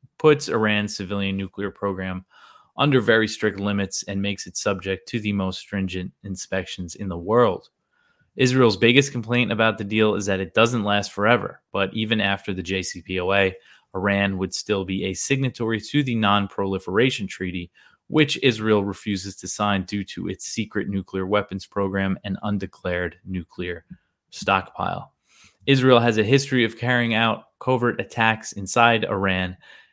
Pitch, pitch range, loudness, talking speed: 100 Hz, 95-115 Hz, -22 LUFS, 150 wpm